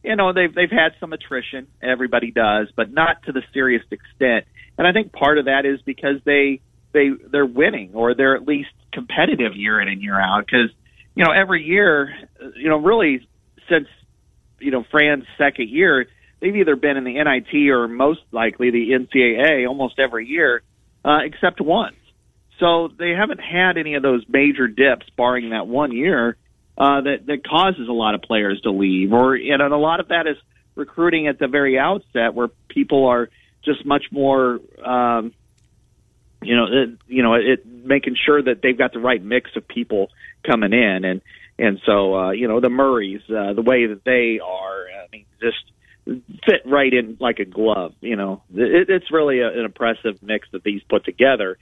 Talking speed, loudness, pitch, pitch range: 190 wpm, -18 LUFS, 130 Hz, 115-145 Hz